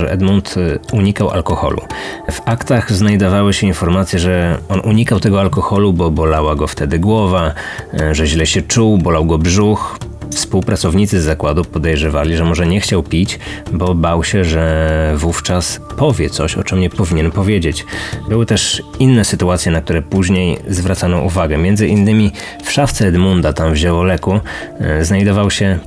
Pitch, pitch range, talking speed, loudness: 95 Hz, 80-100 Hz, 155 wpm, -14 LUFS